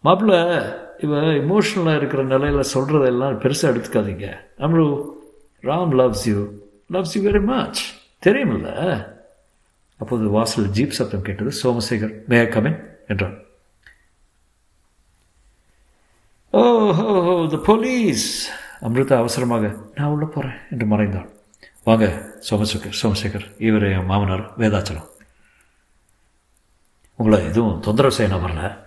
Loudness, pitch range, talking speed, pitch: -19 LUFS, 105-150 Hz, 100 wpm, 115 Hz